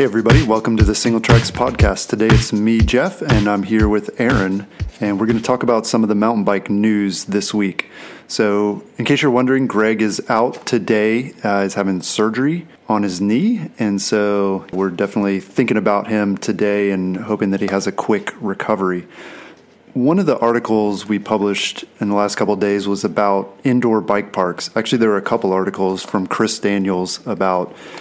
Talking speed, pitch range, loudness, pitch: 190 wpm, 100-115 Hz, -17 LUFS, 105 Hz